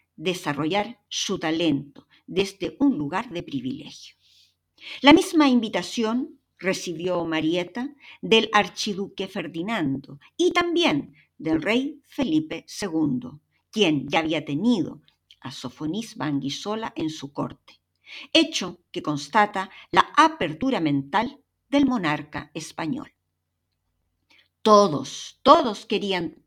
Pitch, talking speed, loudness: 205 Hz, 100 wpm, -24 LUFS